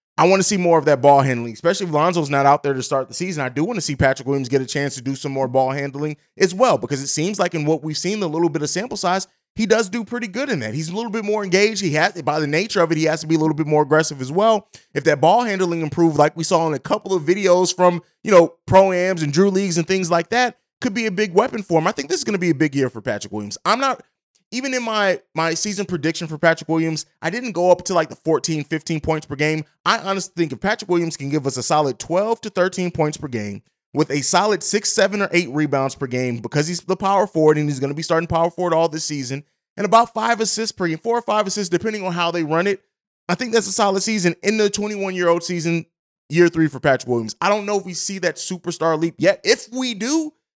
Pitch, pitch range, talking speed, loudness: 170 Hz, 155-200 Hz, 285 wpm, -19 LUFS